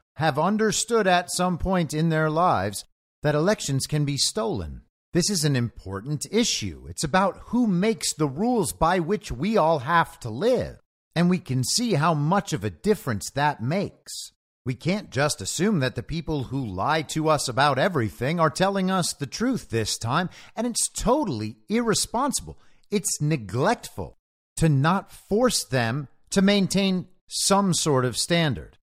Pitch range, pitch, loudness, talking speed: 130-195 Hz, 160 Hz, -24 LUFS, 160 wpm